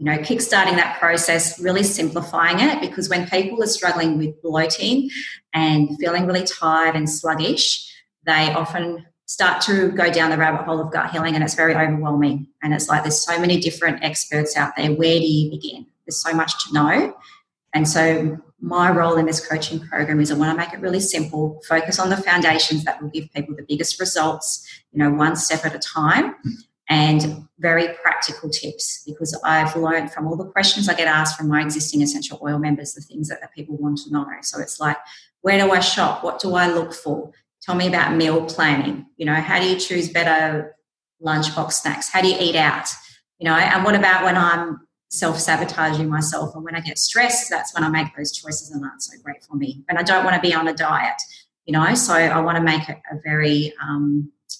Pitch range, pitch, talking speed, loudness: 155-175 Hz, 160 Hz, 215 wpm, -19 LUFS